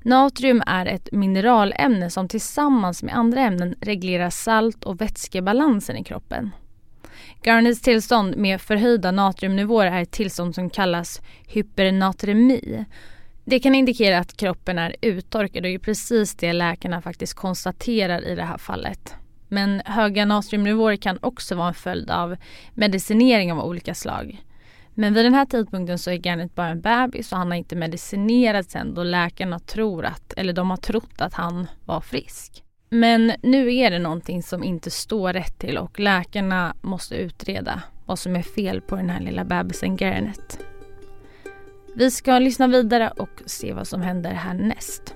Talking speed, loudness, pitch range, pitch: 160 wpm, -21 LUFS, 175-230 Hz, 195 Hz